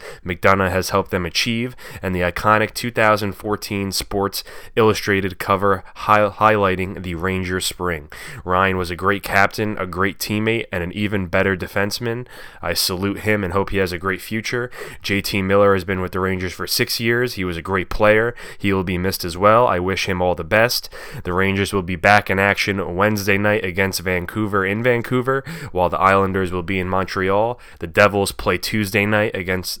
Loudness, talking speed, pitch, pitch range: -19 LUFS, 185 wpm, 100 Hz, 95-105 Hz